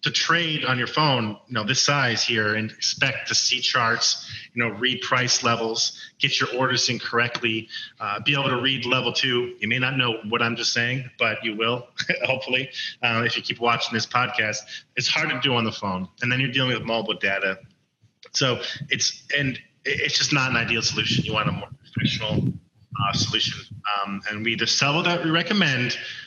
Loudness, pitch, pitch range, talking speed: -22 LUFS, 120 Hz, 115-130 Hz, 205 wpm